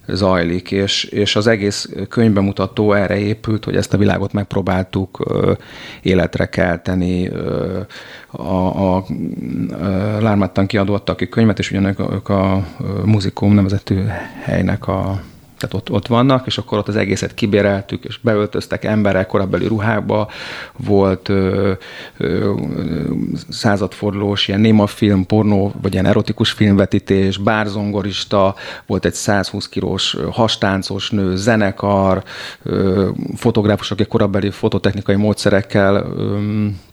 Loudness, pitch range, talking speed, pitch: -17 LUFS, 95-105 Hz, 120 wpm, 100 Hz